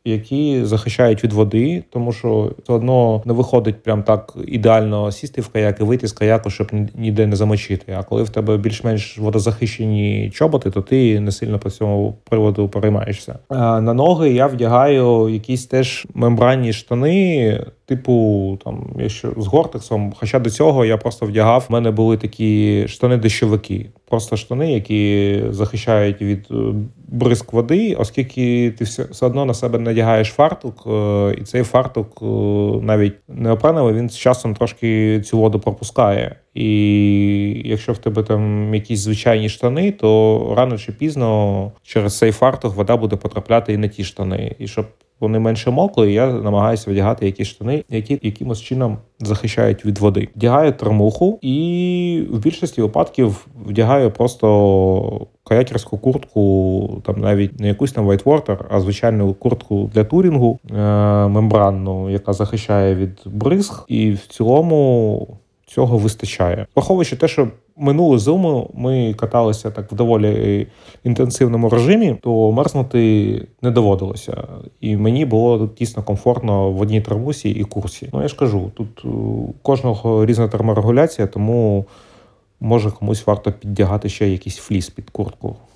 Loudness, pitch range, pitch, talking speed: -17 LUFS, 105-125 Hz, 110 Hz, 145 wpm